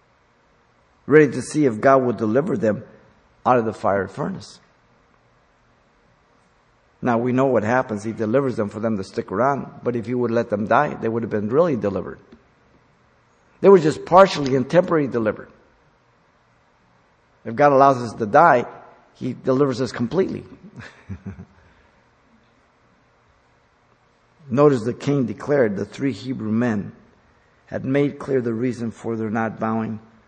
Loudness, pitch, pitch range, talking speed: -20 LUFS, 120 Hz, 110-135 Hz, 145 wpm